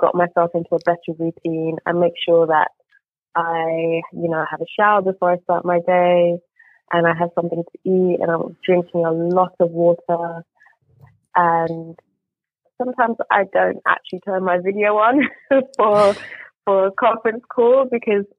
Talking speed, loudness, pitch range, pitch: 160 wpm, -18 LUFS, 170-205 Hz, 175 Hz